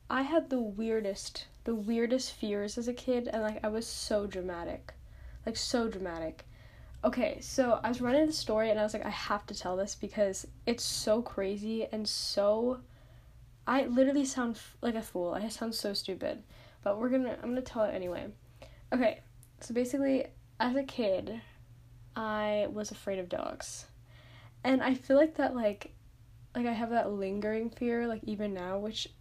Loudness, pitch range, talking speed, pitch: -33 LUFS, 190-245 Hz, 180 wpm, 215 Hz